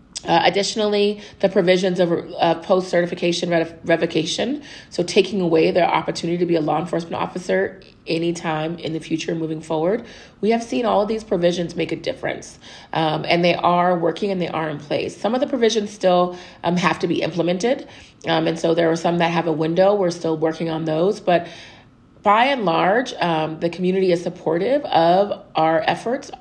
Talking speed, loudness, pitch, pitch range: 190 wpm, -20 LUFS, 175 Hz, 165-195 Hz